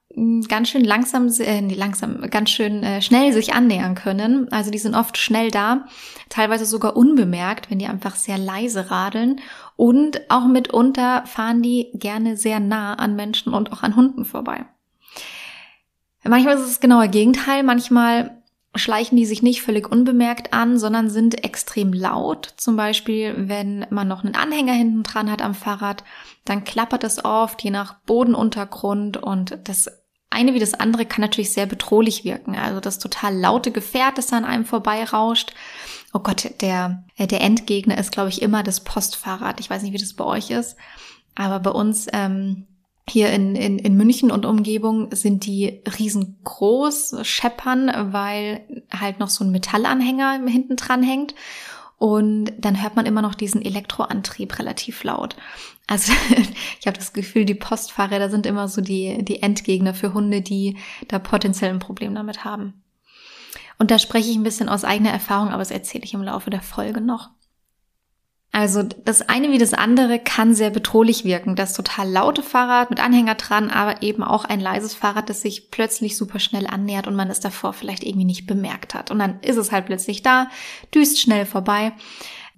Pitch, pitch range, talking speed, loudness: 215 Hz, 205-235 Hz, 175 wpm, -19 LUFS